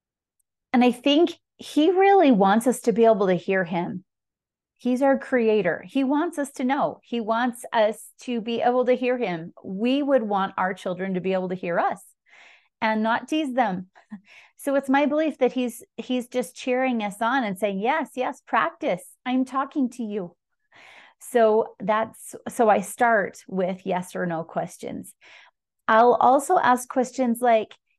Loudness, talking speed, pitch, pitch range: -23 LUFS, 170 wpm, 240 Hz, 205-260 Hz